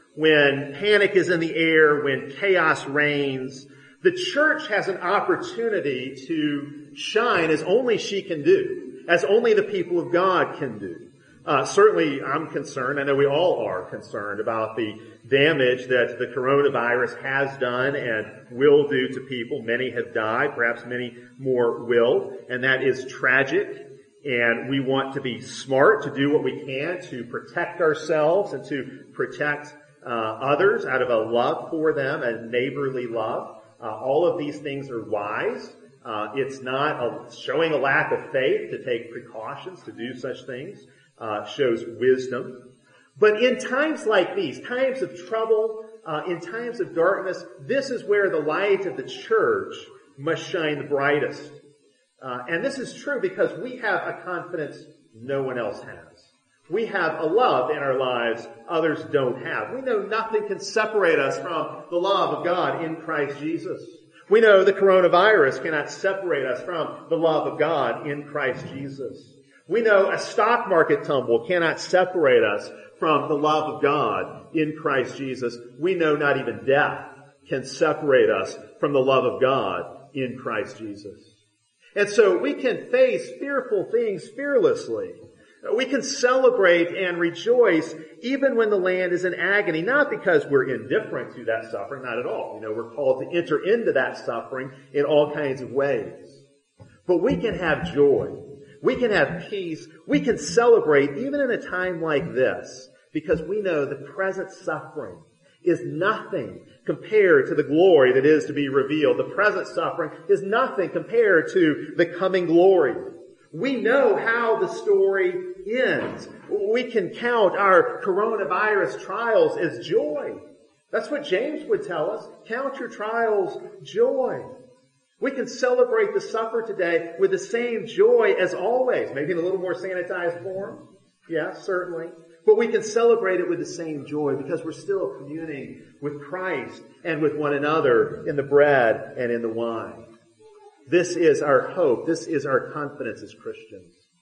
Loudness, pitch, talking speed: -23 LUFS, 180 Hz, 165 wpm